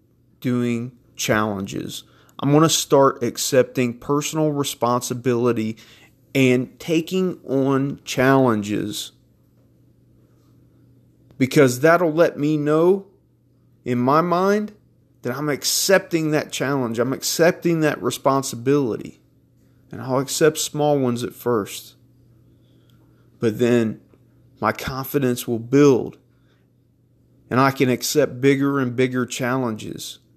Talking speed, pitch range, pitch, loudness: 100 wpm, 120-145 Hz, 130 Hz, -20 LUFS